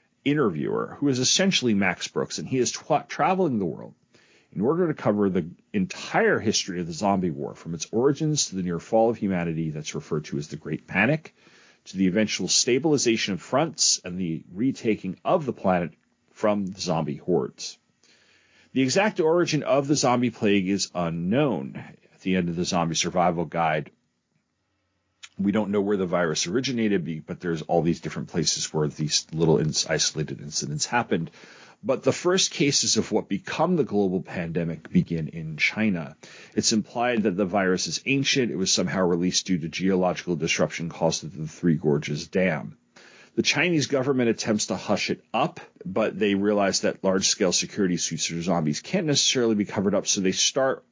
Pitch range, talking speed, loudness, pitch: 85-120 Hz, 180 wpm, -24 LUFS, 100 Hz